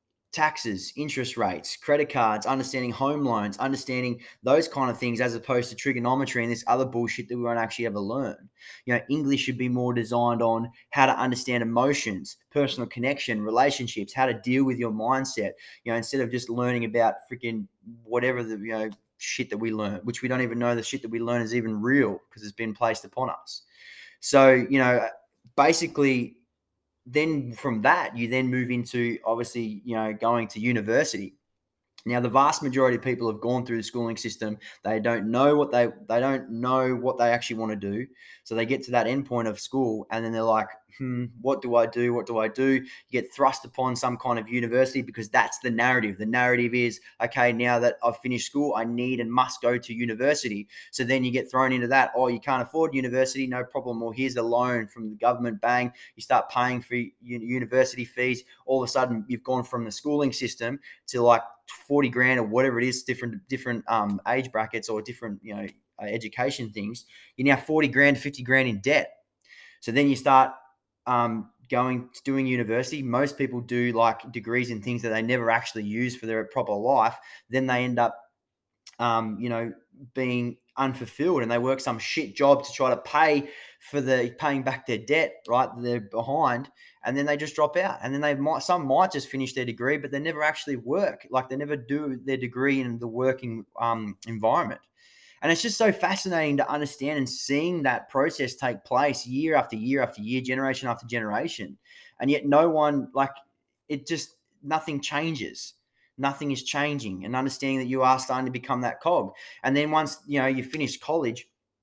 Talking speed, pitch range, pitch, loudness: 205 wpm, 115-135 Hz, 125 Hz, -26 LUFS